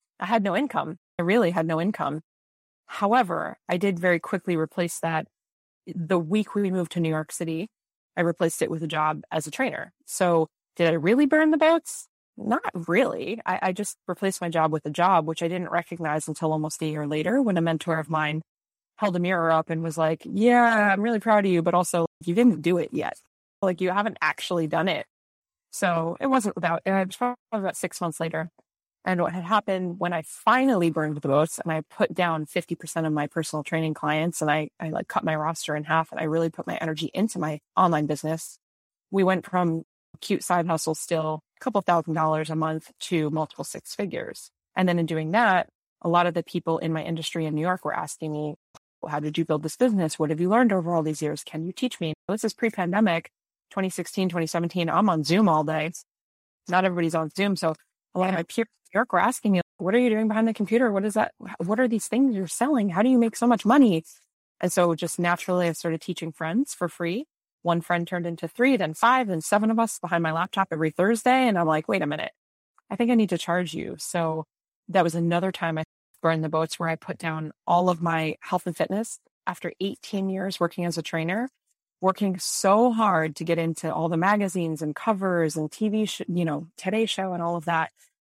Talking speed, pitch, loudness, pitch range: 225 wpm, 175 Hz, -25 LUFS, 160-200 Hz